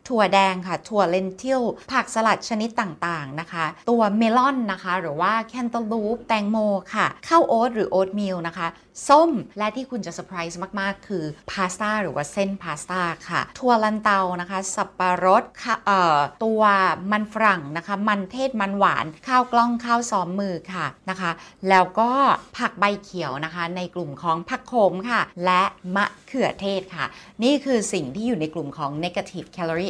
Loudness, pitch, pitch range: -22 LUFS, 195 Hz, 180-225 Hz